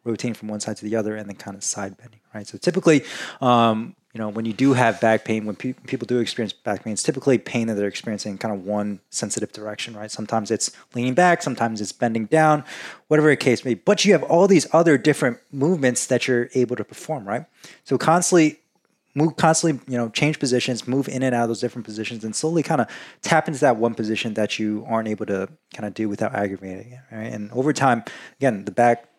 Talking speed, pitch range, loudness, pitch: 235 wpm, 105-135 Hz, -21 LUFS, 120 Hz